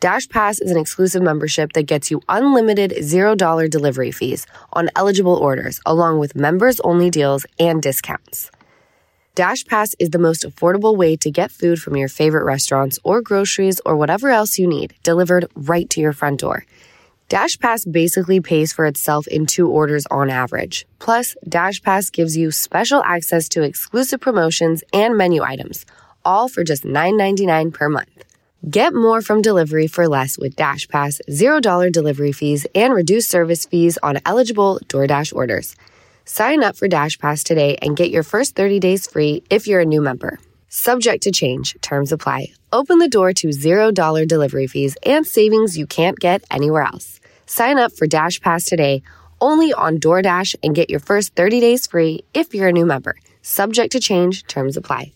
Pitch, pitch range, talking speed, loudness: 170 Hz, 150-200 Hz, 175 wpm, -16 LUFS